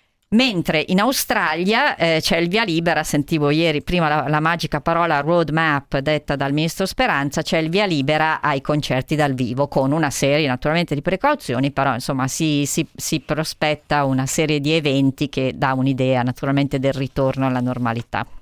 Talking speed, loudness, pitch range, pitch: 170 wpm, -19 LUFS, 135-165 Hz, 150 Hz